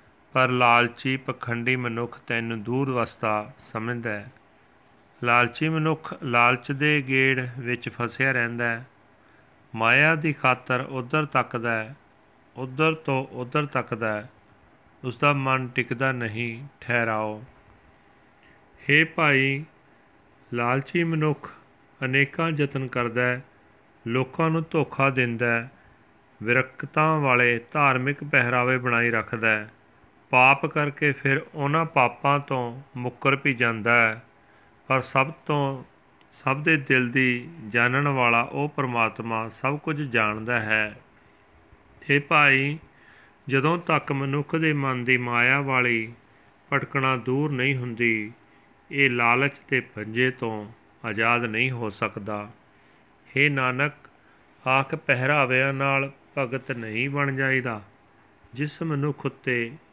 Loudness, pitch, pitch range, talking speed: -23 LUFS, 130 Hz, 120-140 Hz, 115 wpm